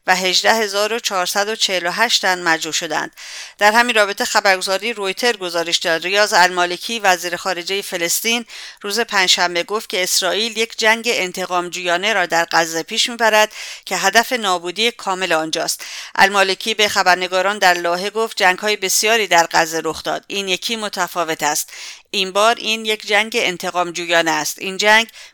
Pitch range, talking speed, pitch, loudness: 175-215 Hz, 150 wpm, 190 Hz, -16 LUFS